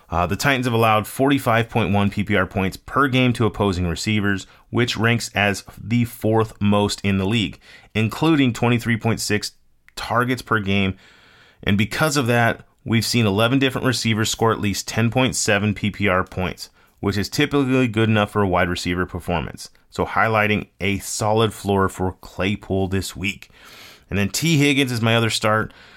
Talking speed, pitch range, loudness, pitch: 160 wpm, 100-120 Hz, -20 LUFS, 105 Hz